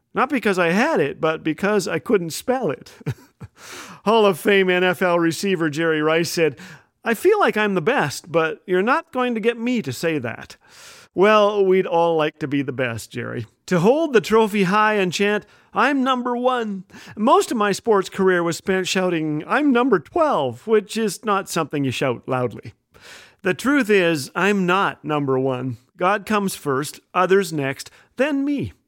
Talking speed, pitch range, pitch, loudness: 180 wpm, 160-220 Hz, 190 Hz, -20 LUFS